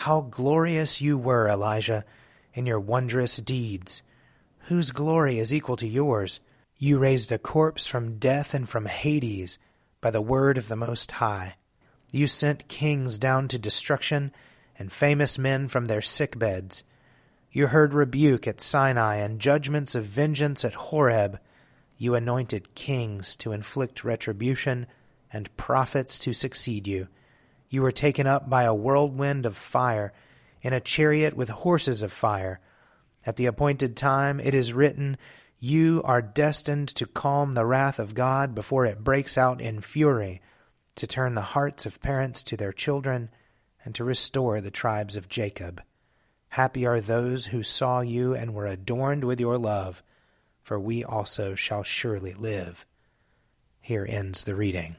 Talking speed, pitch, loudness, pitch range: 155 wpm, 125 Hz, -25 LUFS, 110-140 Hz